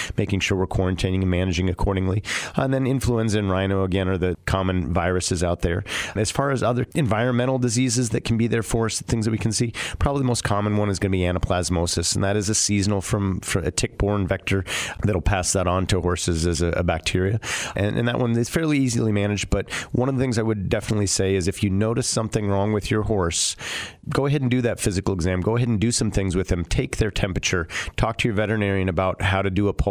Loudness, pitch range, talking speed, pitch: -23 LUFS, 95-115 Hz, 245 wpm, 100 Hz